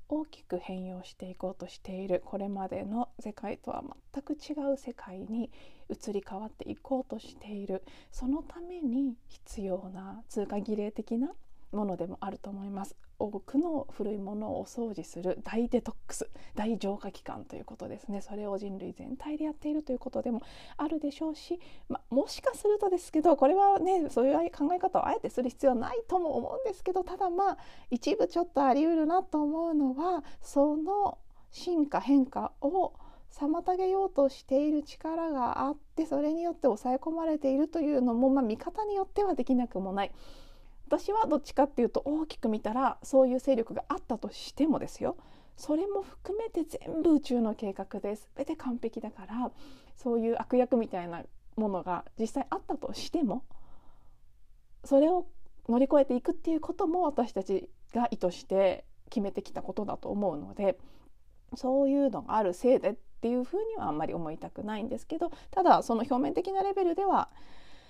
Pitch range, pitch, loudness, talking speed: 215-315 Hz, 265 Hz, -31 LUFS, 360 characters per minute